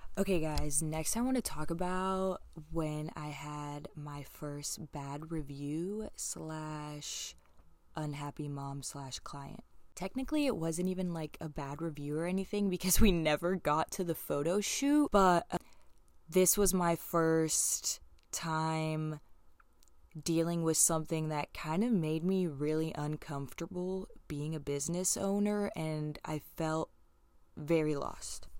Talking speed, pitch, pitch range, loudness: 135 wpm, 160 Hz, 150-180 Hz, -34 LUFS